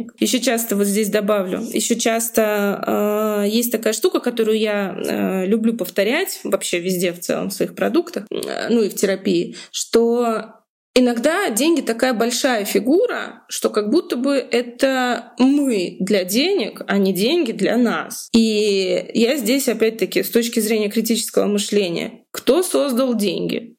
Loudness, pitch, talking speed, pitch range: -19 LUFS, 230 Hz, 150 wpm, 205-250 Hz